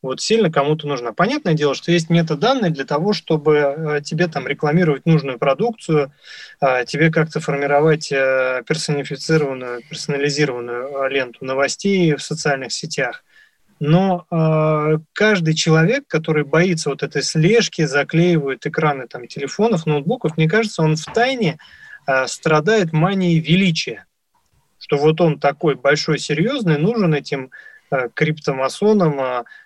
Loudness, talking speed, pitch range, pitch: -18 LUFS, 115 wpm, 145-175 Hz, 155 Hz